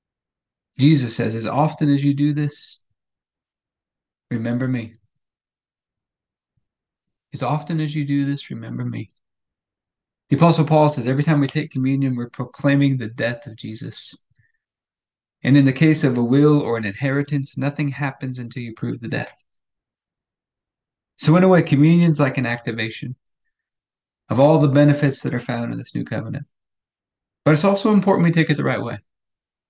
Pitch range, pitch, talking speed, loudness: 120-150 Hz, 140 Hz, 160 wpm, -19 LUFS